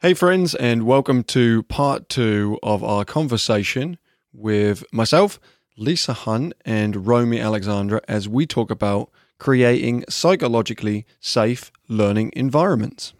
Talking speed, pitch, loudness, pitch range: 120 wpm, 115 Hz, -20 LUFS, 105-140 Hz